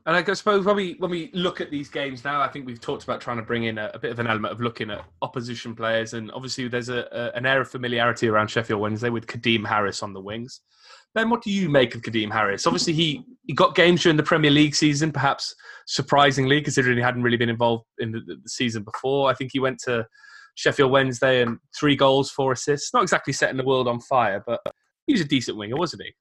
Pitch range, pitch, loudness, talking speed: 120-150 Hz, 130 Hz, -23 LUFS, 250 wpm